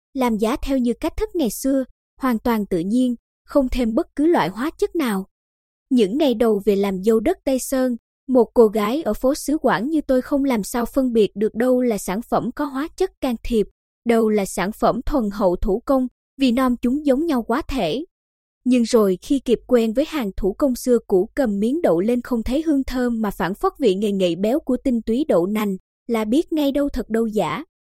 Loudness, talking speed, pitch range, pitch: -20 LUFS, 230 wpm, 220-275 Hz, 245 Hz